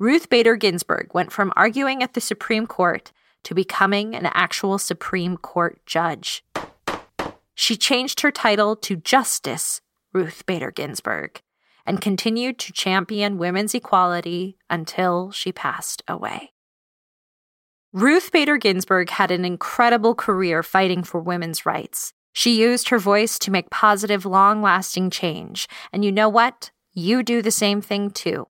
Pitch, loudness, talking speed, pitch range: 200 Hz, -20 LUFS, 140 wpm, 180-225 Hz